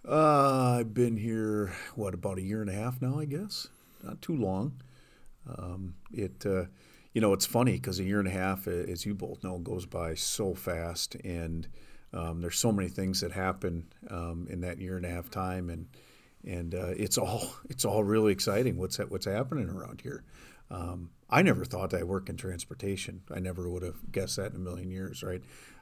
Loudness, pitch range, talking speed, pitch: -32 LUFS, 90-105 Hz, 205 wpm, 95 Hz